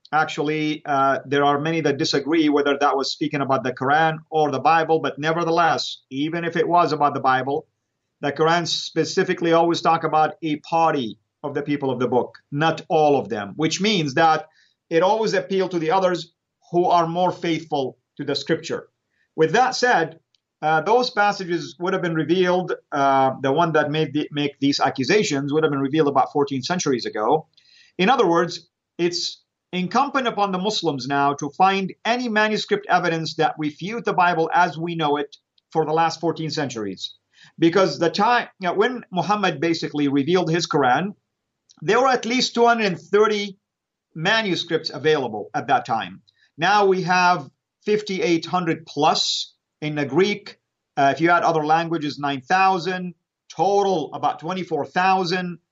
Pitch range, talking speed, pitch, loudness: 145-180 Hz, 165 wpm, 165 Hz, -21 LUFS